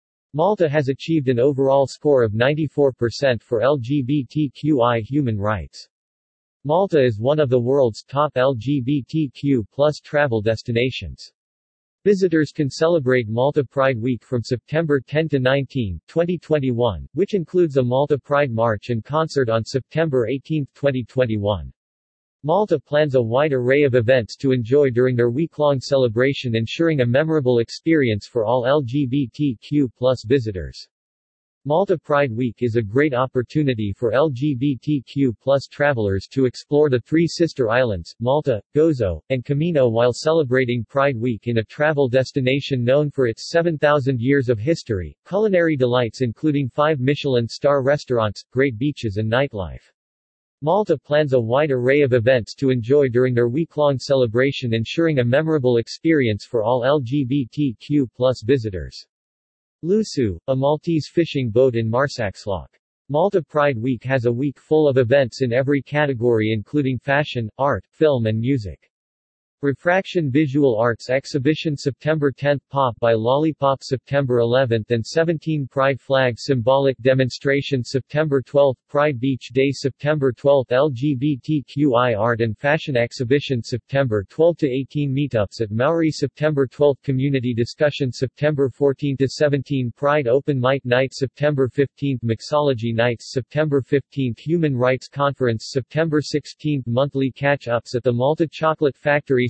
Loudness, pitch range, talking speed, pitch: -20 LUFS, 120-145 Hz, 130 wpm, 135 Hz